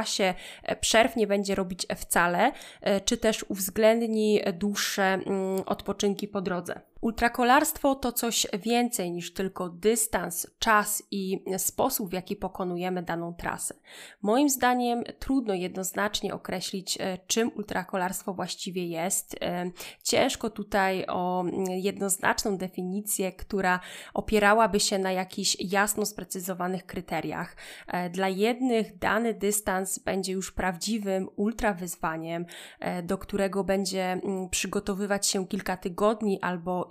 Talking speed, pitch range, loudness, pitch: 105 wpm, 185-215 Hz, -28 LUFS, 195 Hz